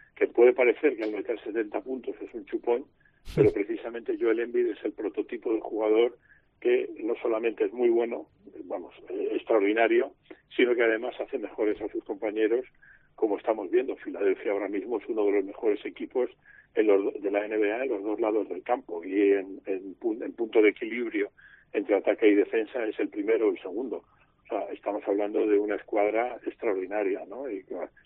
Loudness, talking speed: -28 LUFS, 185 wpm